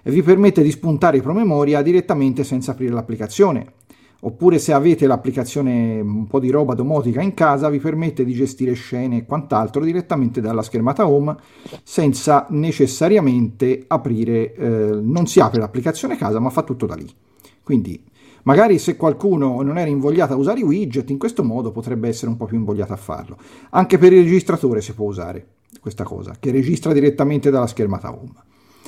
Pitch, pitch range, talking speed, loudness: 135 Hz, 115-155 Hz, 175 wpm, -17 LUFS